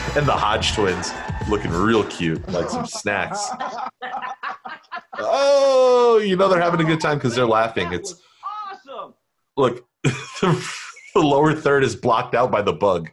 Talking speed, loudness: 150 wpm, -20 LUFS